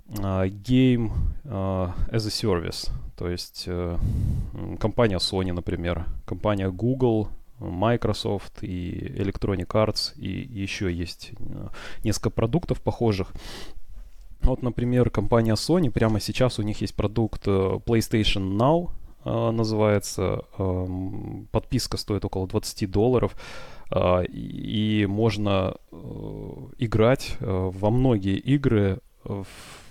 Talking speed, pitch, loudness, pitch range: 115 wpm, 105 Hz, -25 LUFS, 95-115 Hz